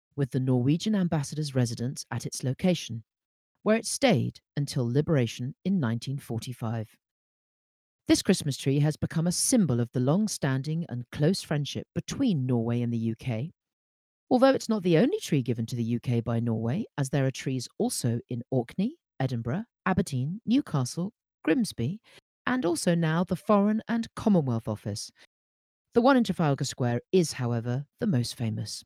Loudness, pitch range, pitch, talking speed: -28 LUFS, 120-185 Hz, 140 Hz, 155 wpm